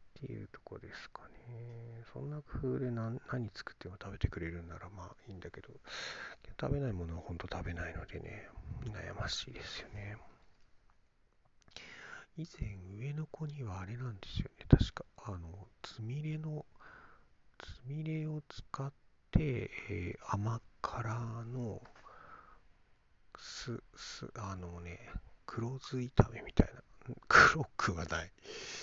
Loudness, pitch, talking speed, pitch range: -37 LUFS, 115 Hz, 245 characters per minute, 95-130 Hz